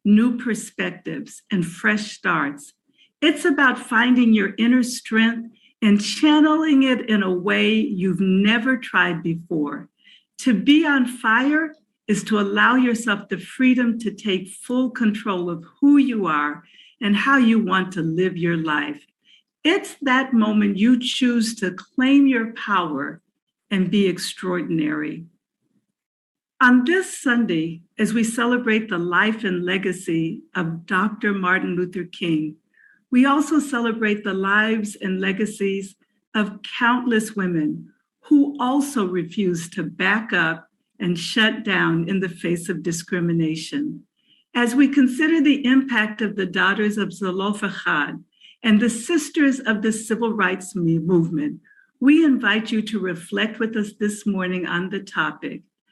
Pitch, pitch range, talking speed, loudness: 210 Hz, 185-250 Hz, 140 wpm, -20 LUFS